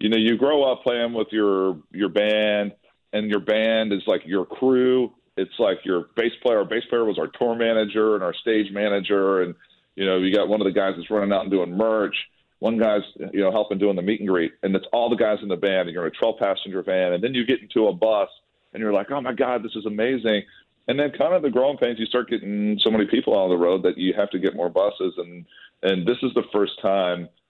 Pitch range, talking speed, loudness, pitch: 95-120 Hz, 260 wpm, -22 LUFS, 105 Hz